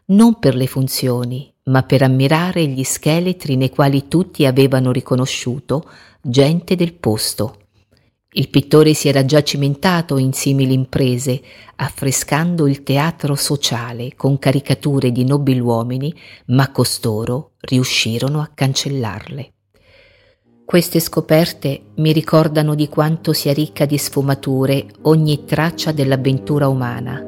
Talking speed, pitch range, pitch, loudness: 120 wpm, 130-150 Hz, 140 Hz, -16 LUFS